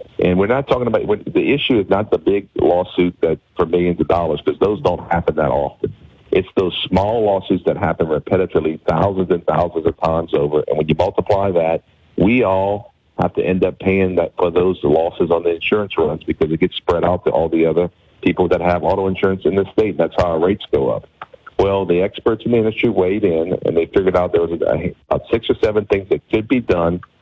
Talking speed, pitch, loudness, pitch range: 230 wpm, 90 Hz, -17 LUFS, 85-100 Hz